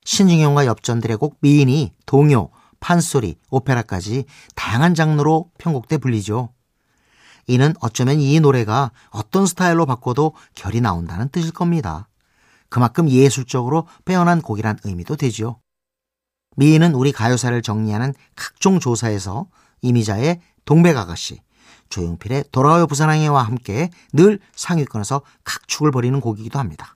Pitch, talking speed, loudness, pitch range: 135 Hz, 320 characters per minute, -18 LUFS, 115-155 Hz